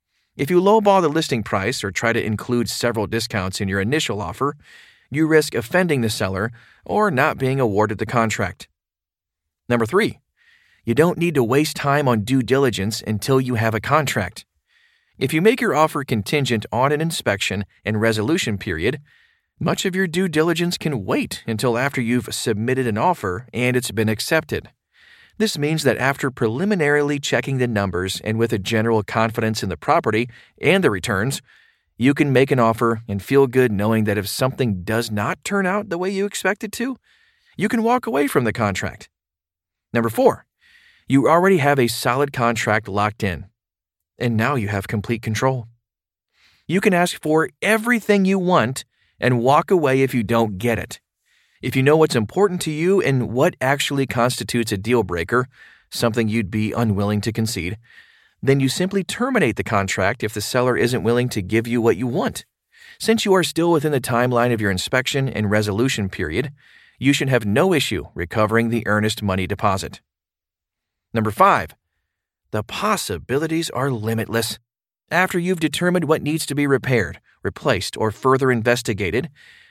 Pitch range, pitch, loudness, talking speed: 110-150 Hz, 120 Hz, -20 LUFS, 170 wpm